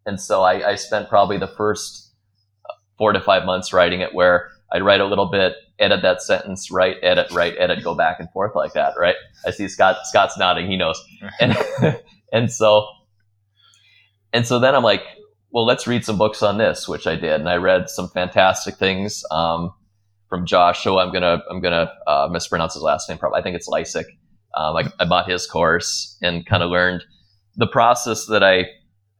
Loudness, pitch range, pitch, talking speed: -19 LUFS, 90-105 Hz, 100 Hz, 200 wpm